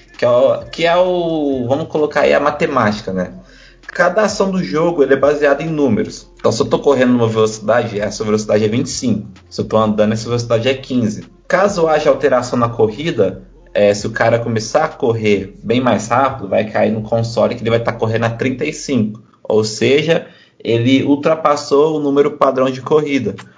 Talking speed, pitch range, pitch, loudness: 195 wpm, 110-145 Hz, 125 Hz, -15 LUFS